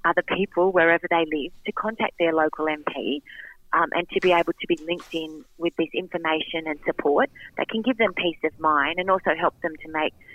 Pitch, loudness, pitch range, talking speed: 170 Hz, -24 LUFS, 155-180 Hz, 215 wpm